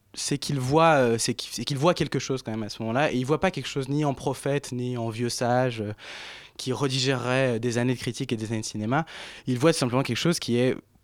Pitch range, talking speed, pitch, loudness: 120-140 Hz, 245 wpm, 130 Hz, -26 LUFS